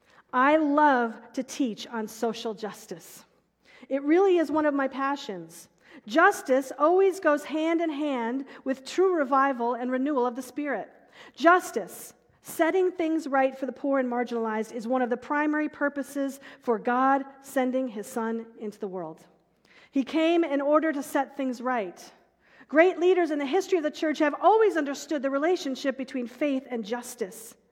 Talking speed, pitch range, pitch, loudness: 165 wpm, 245-305 Hz, 275 Hz, -26 LUFS